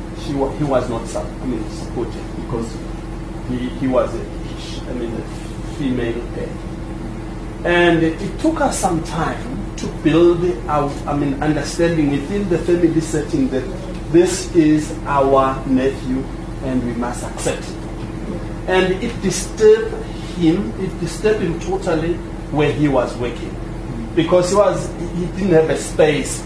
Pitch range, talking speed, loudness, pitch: 135-175 Hz, 135 wpm, -19 LUFS, 160 Hz